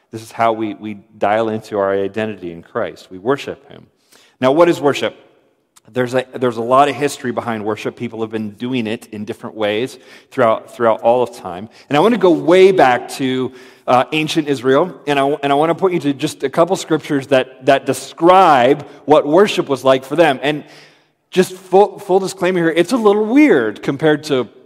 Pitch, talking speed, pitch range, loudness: 135 Hz, 205 wpm, 115-165 Hz, -15 LUFS